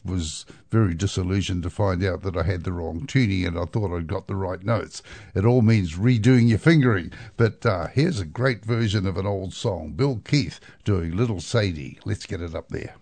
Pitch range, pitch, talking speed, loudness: 90-115 Hz, 100 Hz, 210 wpm, -24 LUFS